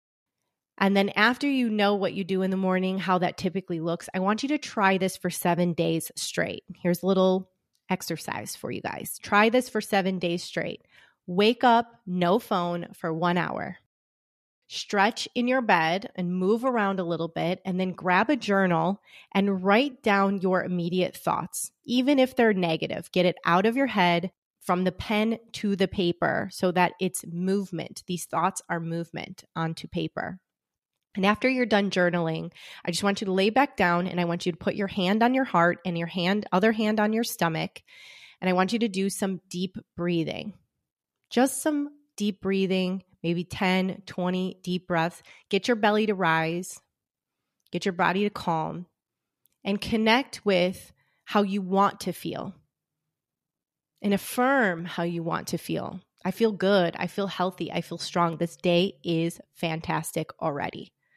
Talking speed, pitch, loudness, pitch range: 180 wpm, 190 Hz, -26 LUFS, 175-210 Hz